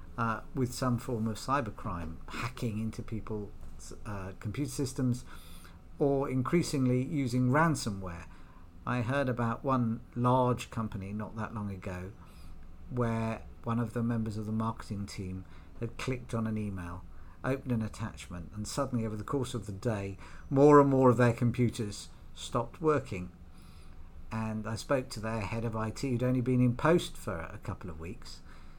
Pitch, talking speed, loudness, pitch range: 110 Hz, 160 wpm, -32 LUFS, 90-125 Hz